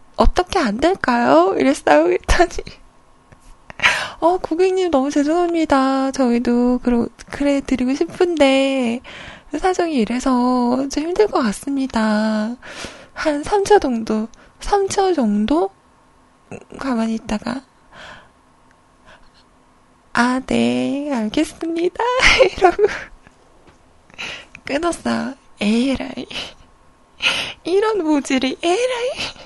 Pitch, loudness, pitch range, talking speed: 280 Hz, -18 LUFS, 245-355 Hz, 185 characters per minute